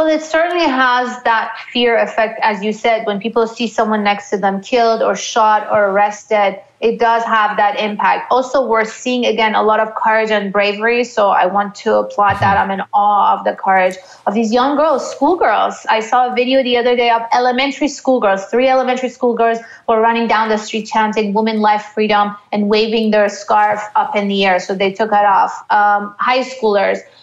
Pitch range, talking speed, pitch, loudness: 205-245 Hz, 205 wpm, 220 Hz, -14 LUFS